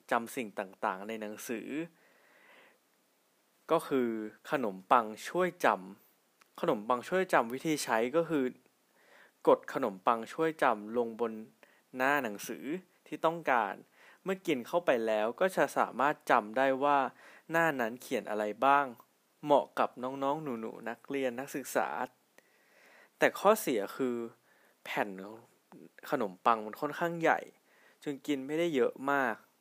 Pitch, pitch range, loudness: 130 Hz, 115-155 Hz, -32 LUFS